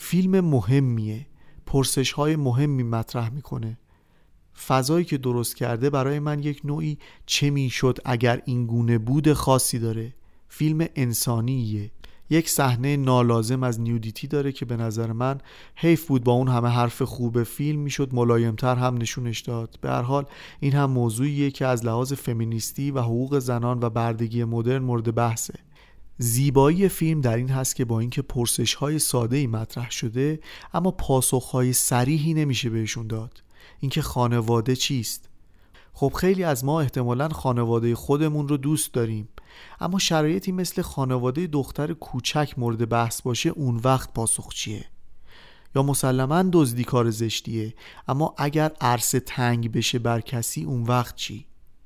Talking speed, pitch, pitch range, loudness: 145 wpm, 130 Hz, 120-145 Hz, -24 LUFS